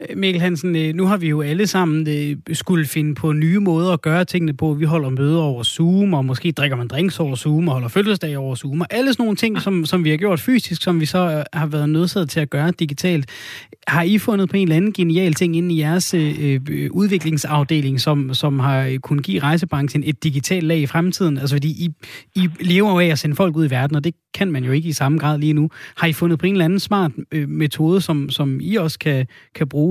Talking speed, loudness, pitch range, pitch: 245 wpm, -18 LUFS, 150-180 Hz, 160 Hz